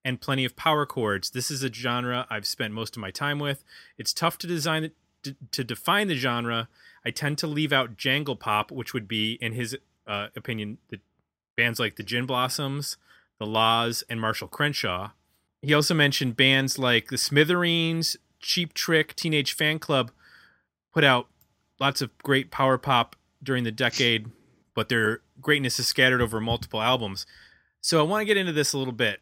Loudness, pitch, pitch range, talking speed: -25 LUFS, 130 Hz, 115-145 Hz, 185 wpm